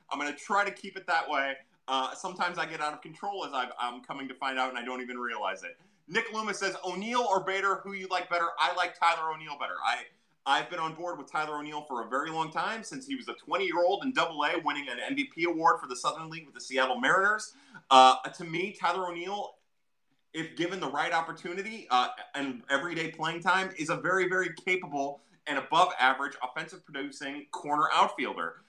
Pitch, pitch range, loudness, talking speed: 170 Hz, 145-190 Hz, -30 LUFS, 215 wpm